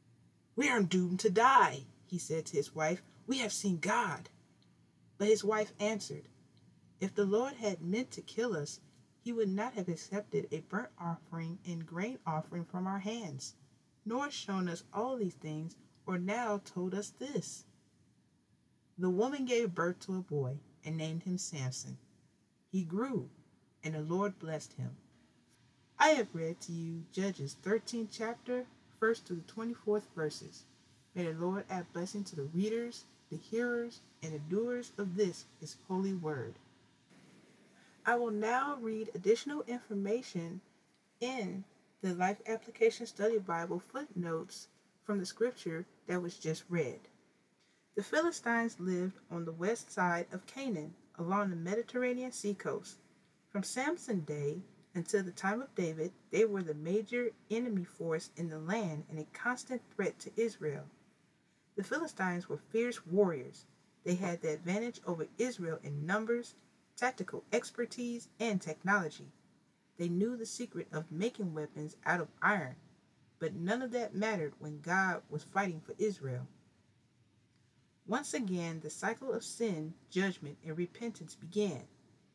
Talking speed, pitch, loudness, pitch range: 150 wpm, 190 Hz, -37 LUFS, 165-220 Hz